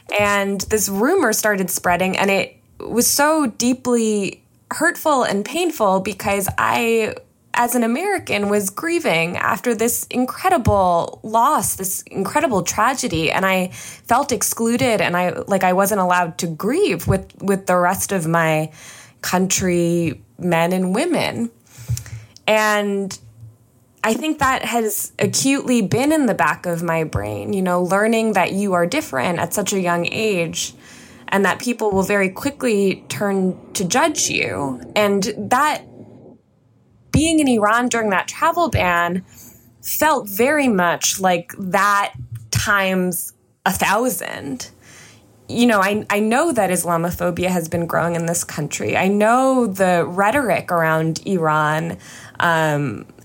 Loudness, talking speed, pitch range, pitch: -18 LUFS, 135 wpm, 170-230 Hz, 195 Hz